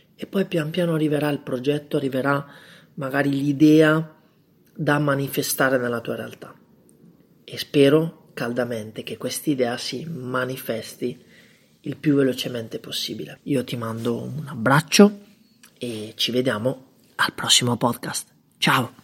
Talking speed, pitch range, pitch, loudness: 125 wpm, 125-155 Hz, 140 Hz, -22 LUFS